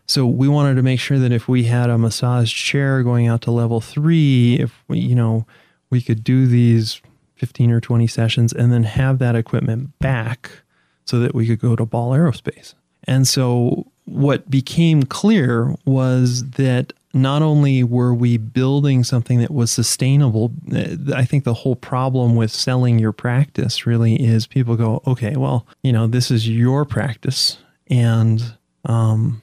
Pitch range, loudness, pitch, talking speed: 115-135 Hz, -17 LUFS, 125 Hz, 170 wpm